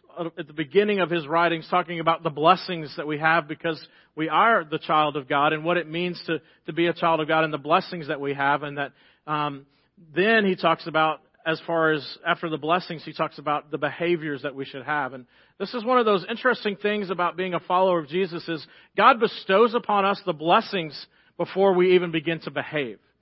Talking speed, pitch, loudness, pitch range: 220 wpm, 165 Hz, -24 LUFS, 155-180 Hz